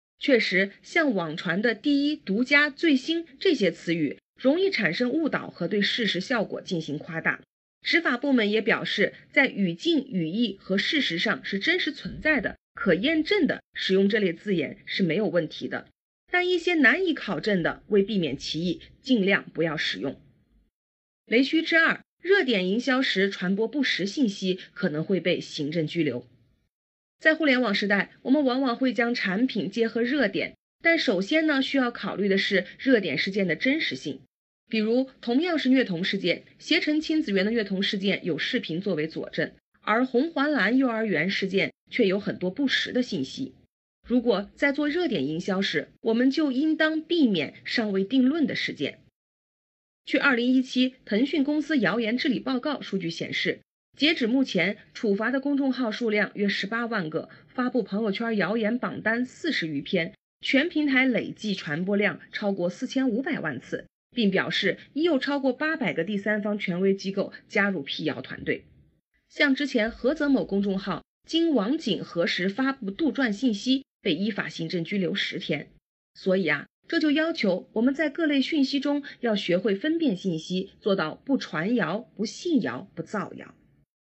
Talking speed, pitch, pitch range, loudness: 260 characters per minute, 225 Hz, 195-275 Hz, -25 LUFS